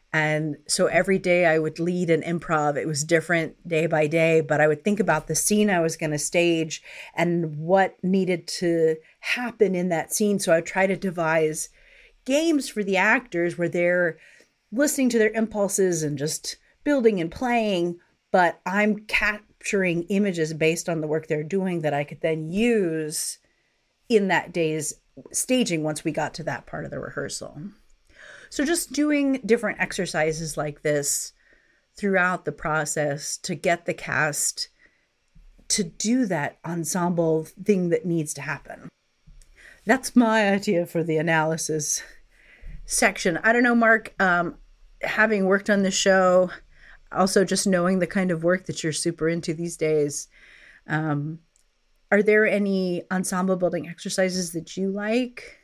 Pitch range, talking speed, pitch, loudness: 160-205 Hz, 160 wpm, 175 Hz, -23 LUFS